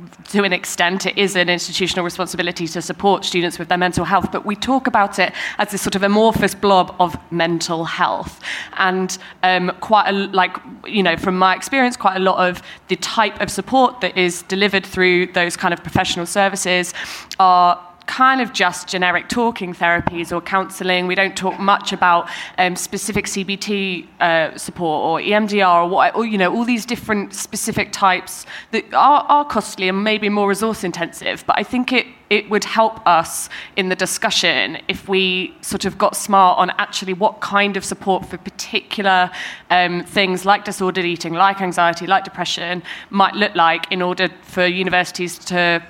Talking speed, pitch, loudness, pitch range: 180 wpm, 185 Hz, -17 LUFS, 180-200 Hz